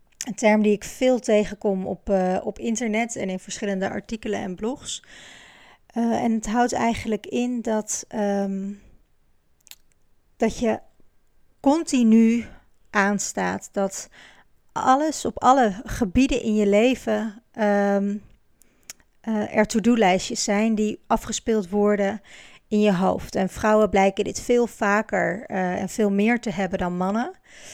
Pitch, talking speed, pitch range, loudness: 215 Hz, 130 wpm, 200-230 Hz, -23 LUFS